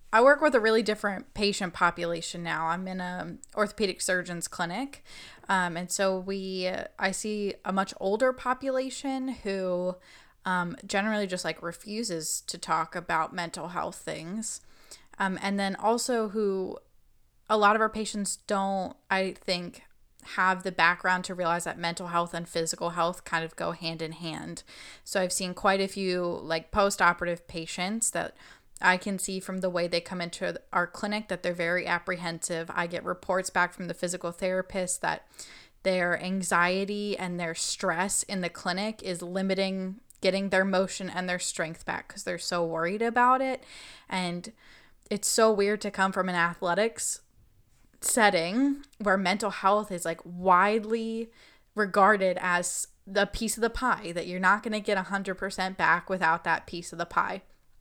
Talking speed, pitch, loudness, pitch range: 170 wpm, 185 Hz, -28 LUFS, 175-205 Hz